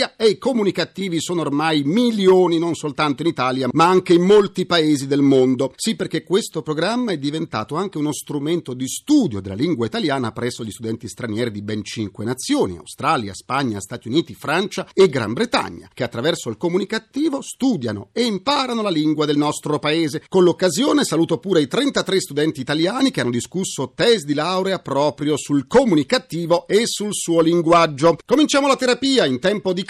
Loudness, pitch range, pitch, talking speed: -19 LUFS, 140-195 Hz, 165 Hz, 175 wpm